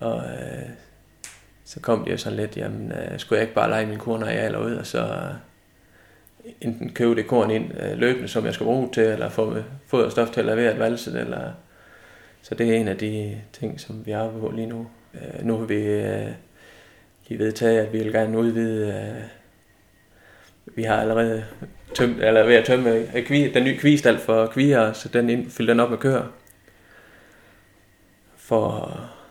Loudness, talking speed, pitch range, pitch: -22 LUFS, 195 wpm, 105-115 Hz, 110 Hz